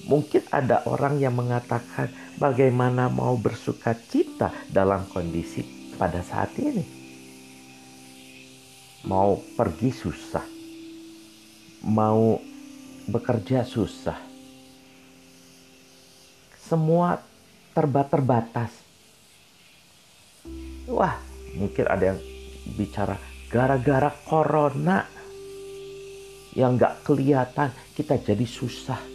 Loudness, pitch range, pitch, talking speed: -25 LUFS, 95-145 Hz, 125 Hz, 70 wpm